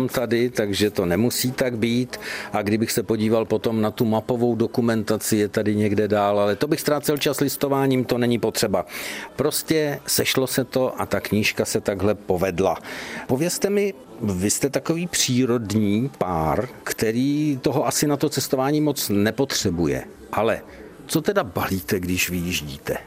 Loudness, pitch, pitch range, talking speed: -22 LUFS, 120 Hz, 105-140 Hz, 155 wpm